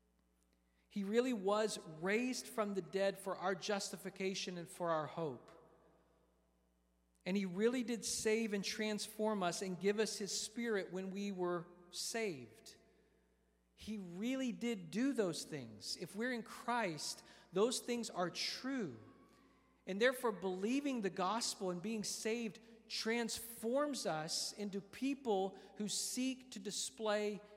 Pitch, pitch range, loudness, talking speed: 200 Hz, 175-225 Hz, -40 LUFS, 135 wpm